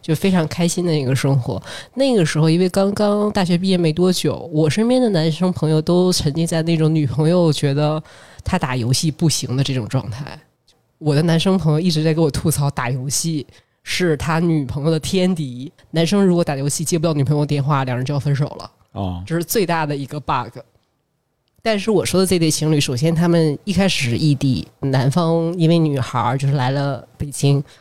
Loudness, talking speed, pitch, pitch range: -18 LUFS, 305 characters per minute, 155 Hz, 140-170 Hz